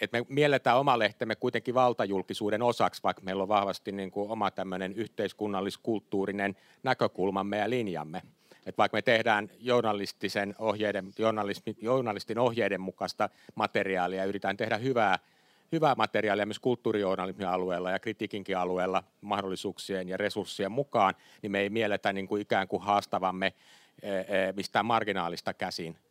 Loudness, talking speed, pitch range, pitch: -30 LUFS, 130 wpm, 95-110 Hz, 100 Hz